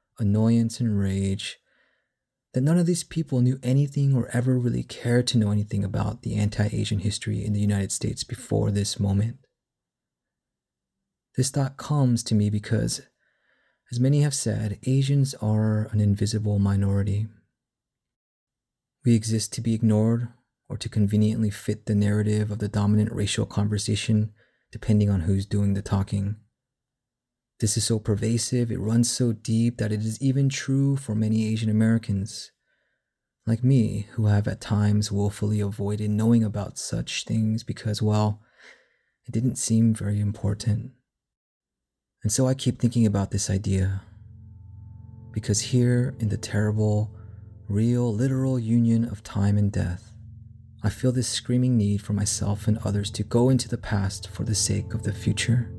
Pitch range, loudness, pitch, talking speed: 105-120 Hz, -25 LUFS, 110 Hz, 155 wpm